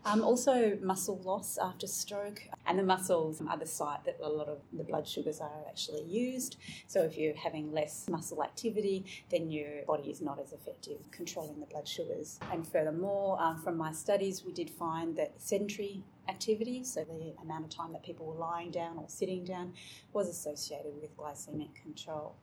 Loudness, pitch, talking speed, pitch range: -36 LUFS, 170 Hz, 185 wpm, 155-195 Hz